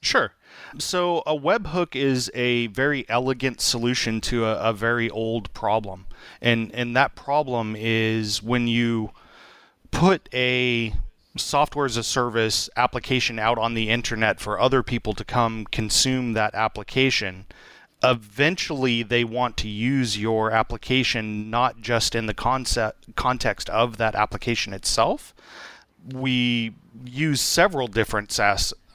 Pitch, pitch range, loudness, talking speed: 120 Hz, 110-130 Hz, -23 LUFS, 130 wpm